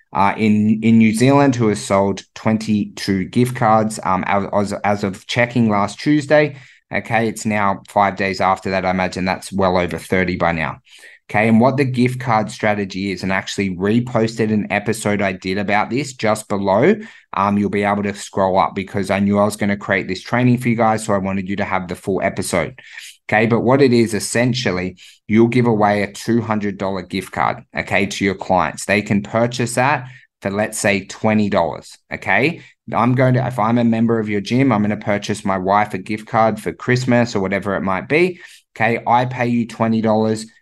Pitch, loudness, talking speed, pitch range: 105 Hz, -18 LUFS, 210 wpm, 100-115 Hz